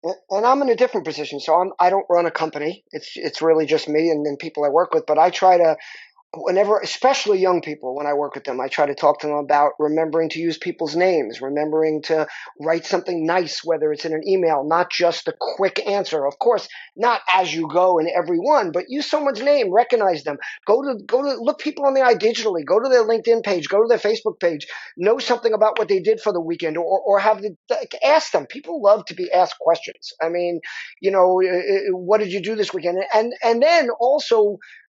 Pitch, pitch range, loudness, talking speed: 180 Hz, 160-215 Hz, -19 LUFS, 230 wpm